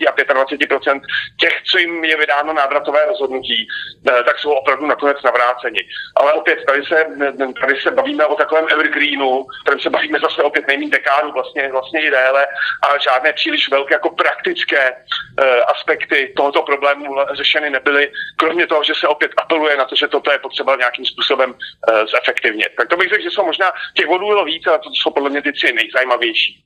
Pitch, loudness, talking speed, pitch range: 145 Hz, -15 LUFS, 180 wpm, 135-155 Hz